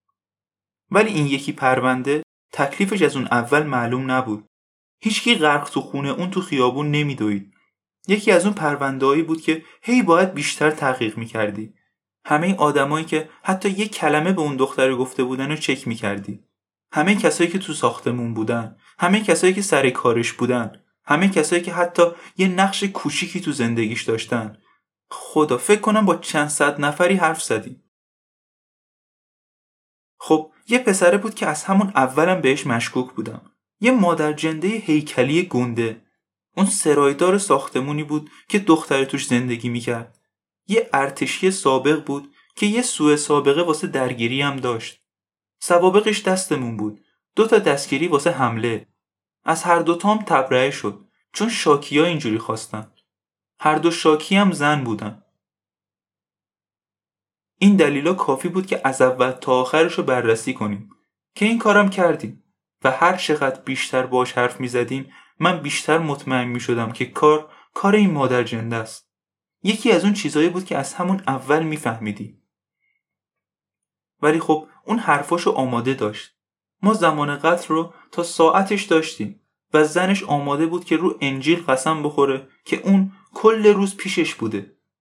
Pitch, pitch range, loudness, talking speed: 150 Hz, 125-175 Hz, -20 LUFS, 150 wpm